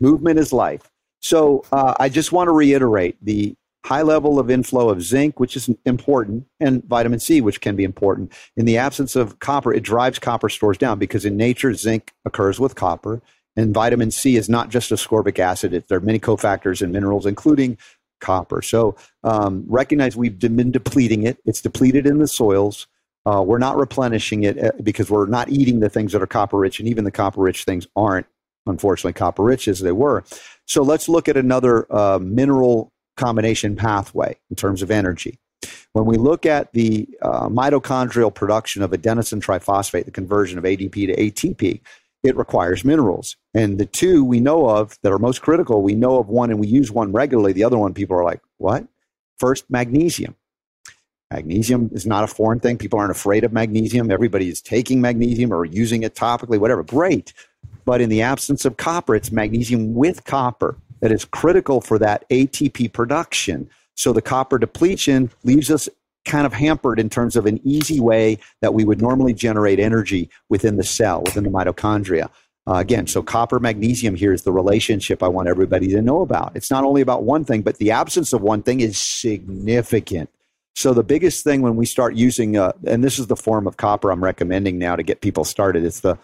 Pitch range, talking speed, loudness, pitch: 105-130 Hz, 195 wpm, -18 LUFS, 115 Hz